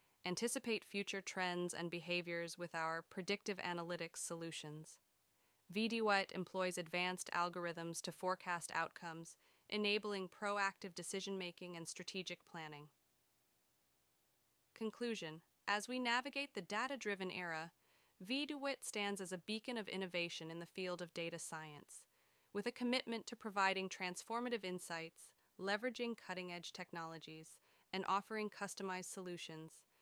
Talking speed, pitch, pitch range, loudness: 120 wpm, 185 Hz, 170-210 Hz, -43 LUFS